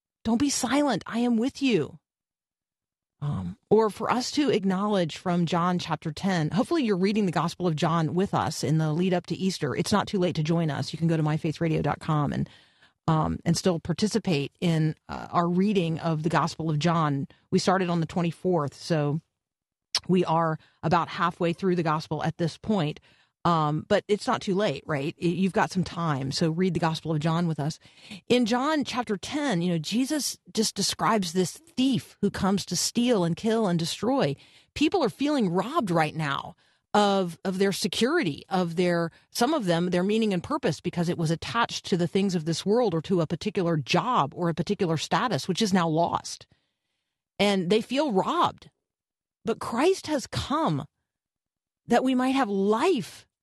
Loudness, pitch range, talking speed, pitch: -26 LUFS, 160-210 Hz, 190 wpm, 180 Hz